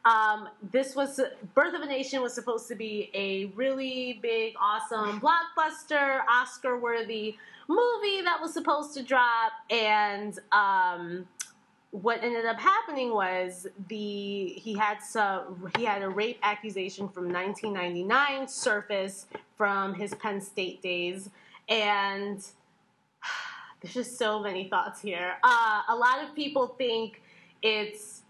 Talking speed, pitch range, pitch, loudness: 130 wpm, 205-265 Hz, 220 Hz, -28 LUFS